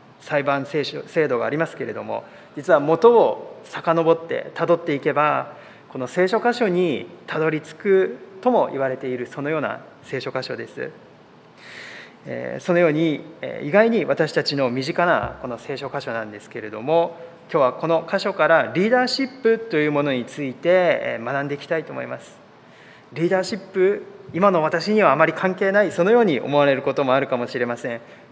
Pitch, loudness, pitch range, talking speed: 165 Hz, -21 LUFS, 140-195 Hz, 355 characters per minute